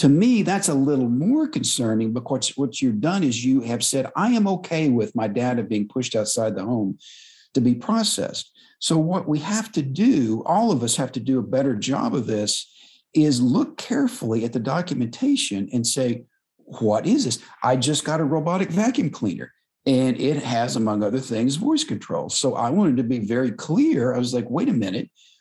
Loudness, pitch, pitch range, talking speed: -22 LUFS, 135 Hz, 120-185 Hz, 200 wpm